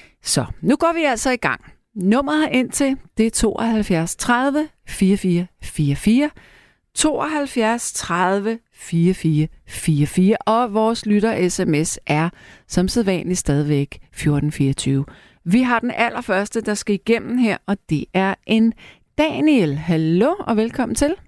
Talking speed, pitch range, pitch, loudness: 125 wpm, 170-235 Hz, 210 Hz, -19 LUFS